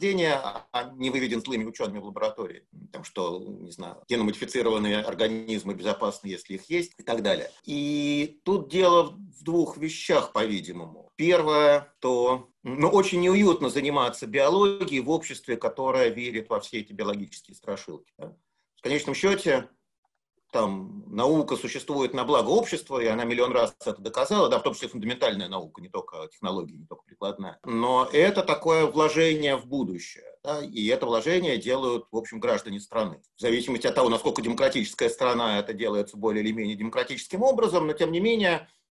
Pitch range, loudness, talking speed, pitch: 115-170 Hz, -26 LUFS, 160 wpm, 140 Hz